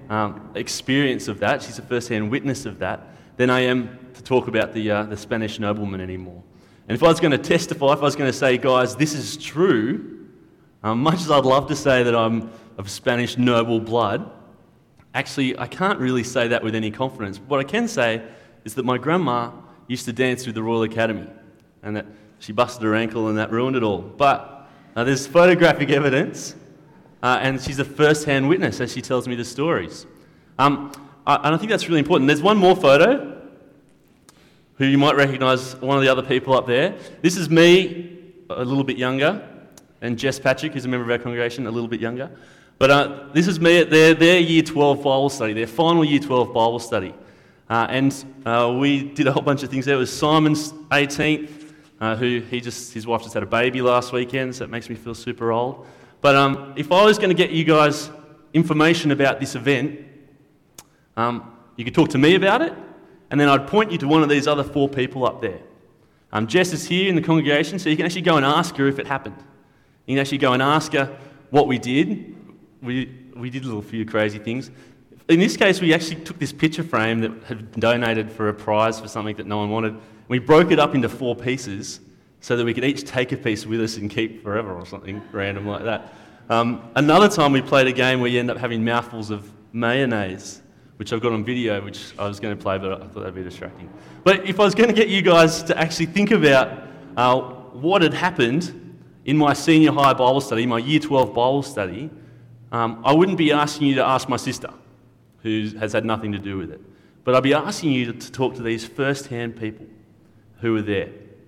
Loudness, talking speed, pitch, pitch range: -20 LUFS, 220 wpm, 130 Hz, 115-145 Hz